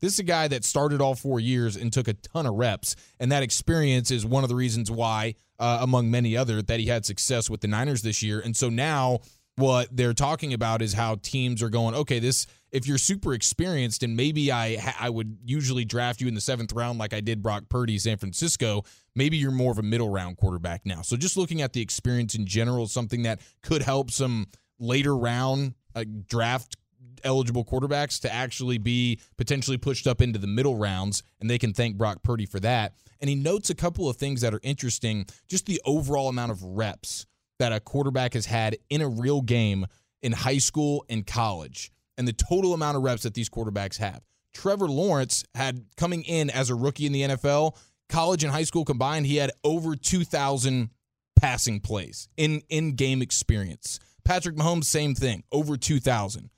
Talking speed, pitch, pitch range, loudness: 205 wpm, 125 Hz, 115-140 Hz, -26 LUFS